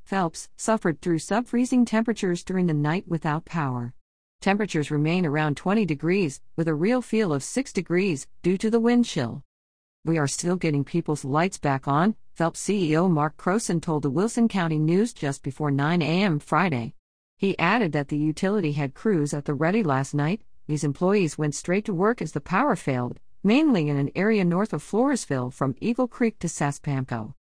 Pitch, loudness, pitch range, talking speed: 165 Hz, -25 LUFS, 145-200 Hz, 185 wpm